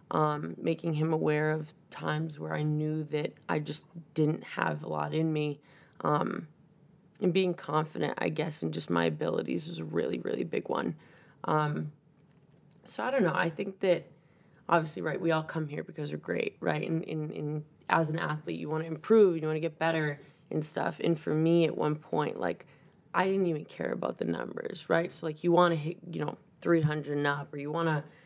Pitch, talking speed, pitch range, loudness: 160 Hz, 210 wpm, 150-170 Hz, -31 LUFS